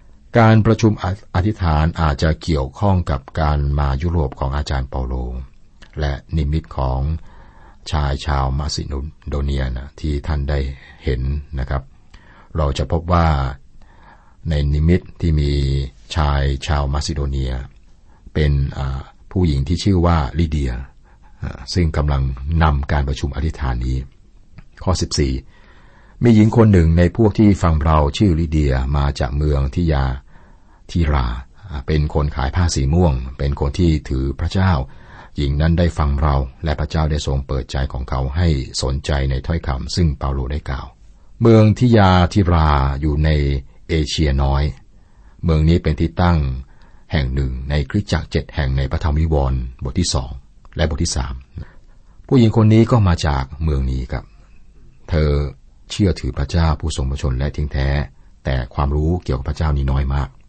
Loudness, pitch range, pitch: -19 LUFS, 70-85 Hz, 75 Hz